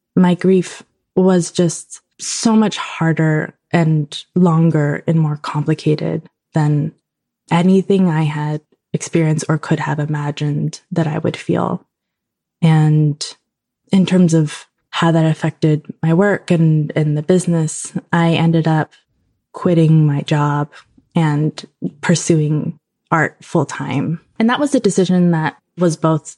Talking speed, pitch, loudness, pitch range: 125 wpm, 160 Hz, -16 LUFS, 155-175 Hz